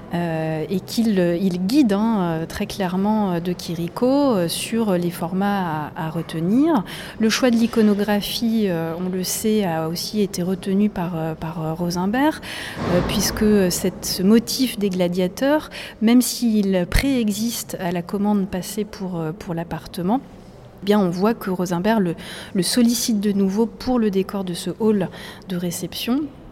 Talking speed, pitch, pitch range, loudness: 145 wpm, 195 Hz, 175-220 Hz, -21 LUFS